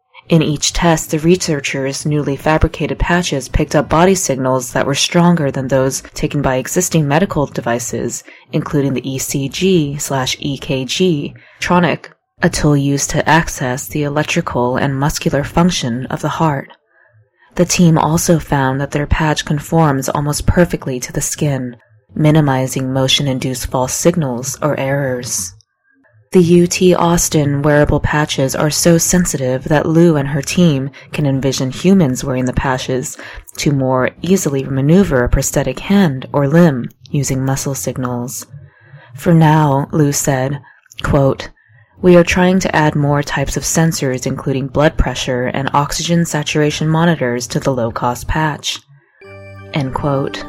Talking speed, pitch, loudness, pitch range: 140 wpm, 145 Hz, -15 LUFS, 130-160 Hz